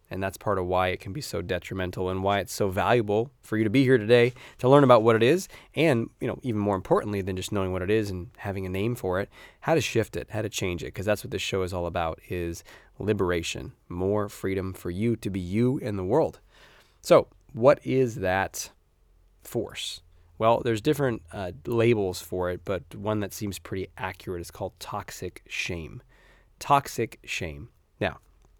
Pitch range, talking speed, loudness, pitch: 90-115 Hz, 205 wpm, -26 LUFS, 100 Hz